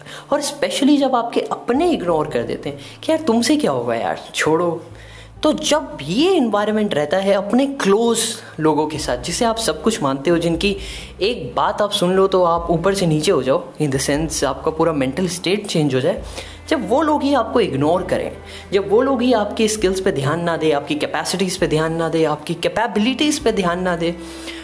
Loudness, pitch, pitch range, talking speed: -18 LUFS, 185 Hz, 160-230 Hz, 205 wpm